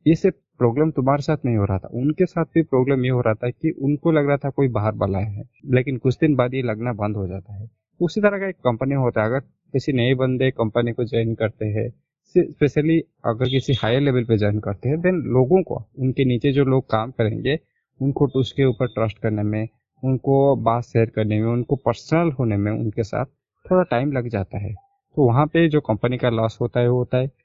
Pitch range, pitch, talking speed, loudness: 115-145 Hz, 130 Hz, 225 wpm, -21 LUFS